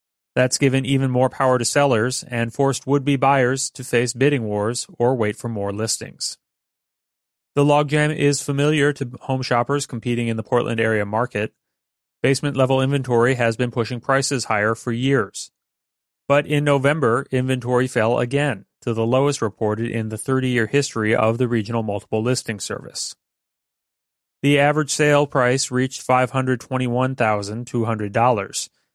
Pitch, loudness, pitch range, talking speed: 125 Hz, -20 LUFS, 115-140 Hz, 145 wpm